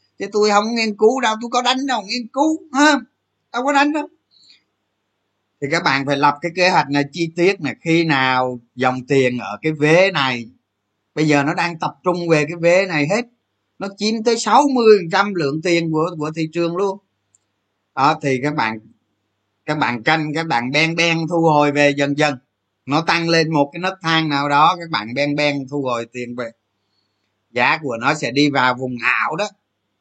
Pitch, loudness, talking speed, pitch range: 150 Hz, -17 LUFS, 200 wpm, 125-180 Hz